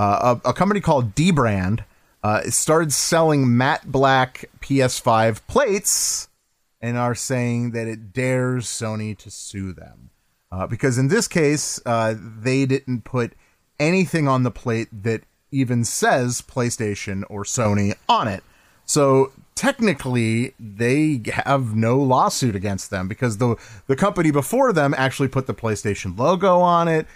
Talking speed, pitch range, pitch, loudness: 145 wpm, 110-140 Hz, 125 Hz, -20 LUFS